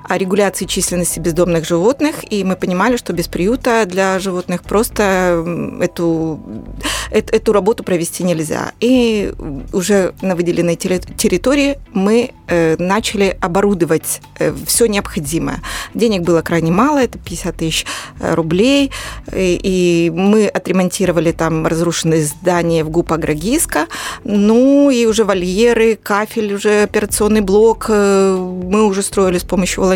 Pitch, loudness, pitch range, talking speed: 190 Hz, -15 LUFS, 175-215 Hz, 120 wpm